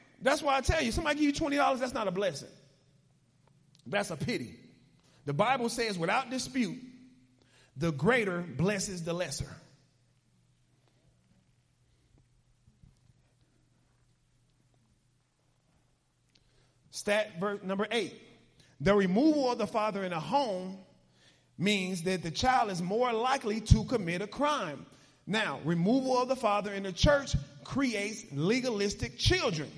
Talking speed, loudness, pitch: 120 wpm, -30 LUFS, 185 Hz